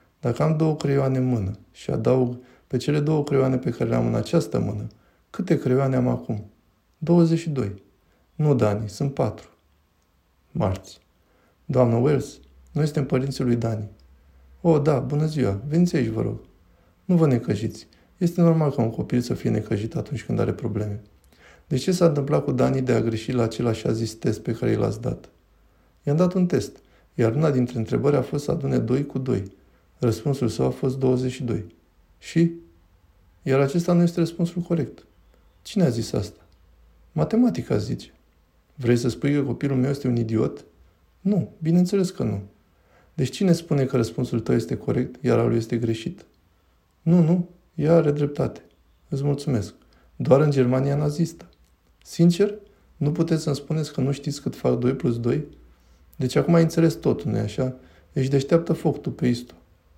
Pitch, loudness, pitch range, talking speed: 125 Hz, -23 LUFS, 95-145 Hz, 175 wpm